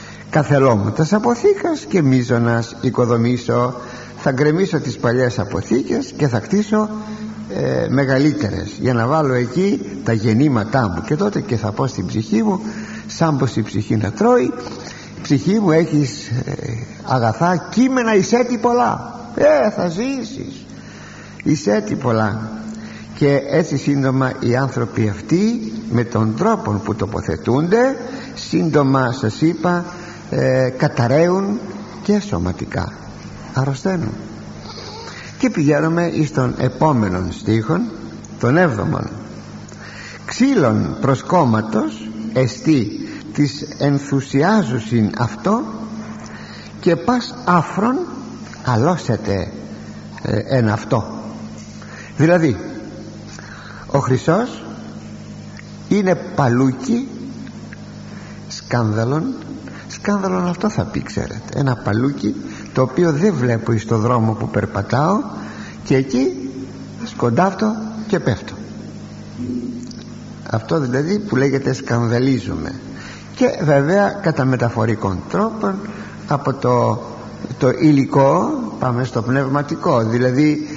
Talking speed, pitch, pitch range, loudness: 100 wpm, 135 Hz, 115-185 Hz, -18 LUFS